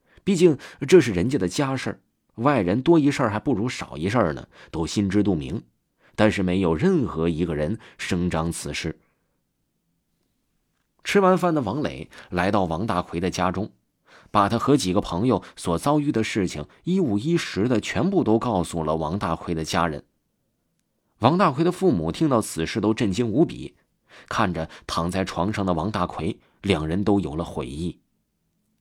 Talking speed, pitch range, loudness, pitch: 240 characters per minute, 85-135 Hz, -23 LUFS, 100 Hz